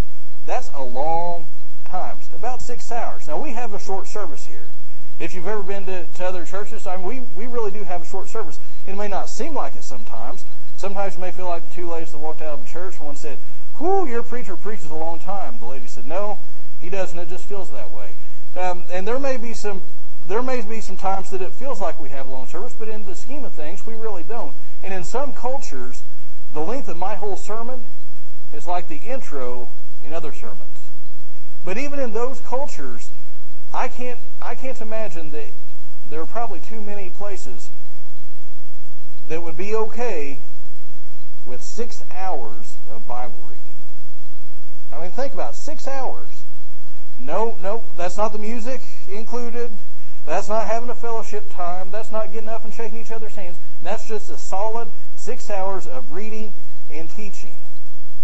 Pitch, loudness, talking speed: 190 Hz, -30 LUFS, 190 wpm